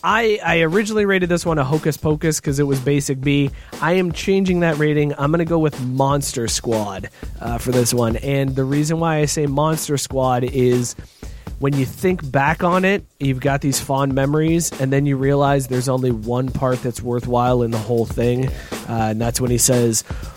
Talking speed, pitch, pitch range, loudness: 205 wpm, 140 Hz, 125-155 Hz, -19 LUFS